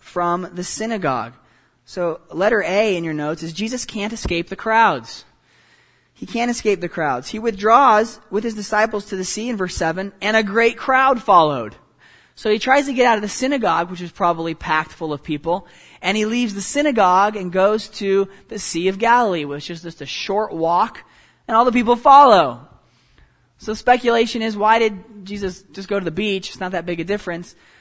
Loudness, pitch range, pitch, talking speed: -18 LUFS, 175-225 Hz, 205 Hz, 200 wpm